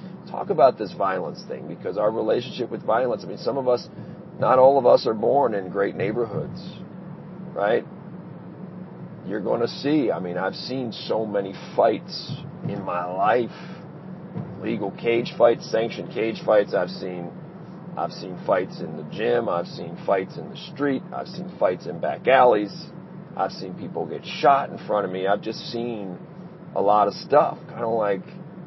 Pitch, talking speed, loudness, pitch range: 135 Hz, 175 wpm, -23 LUFS, 105-175 Hz